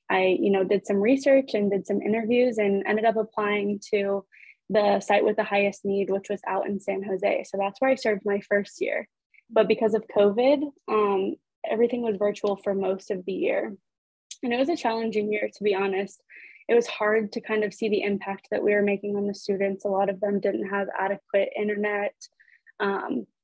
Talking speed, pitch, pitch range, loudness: 210 wpm, 205 Hz, 200-220 Hz, -25 LUFS